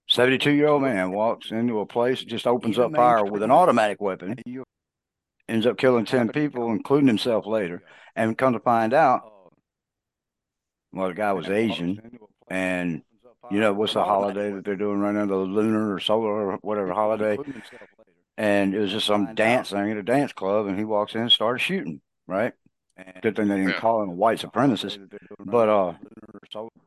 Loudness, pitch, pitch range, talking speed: -23 LUFS, 105 Hz, 100-120 Hz, 185 wpm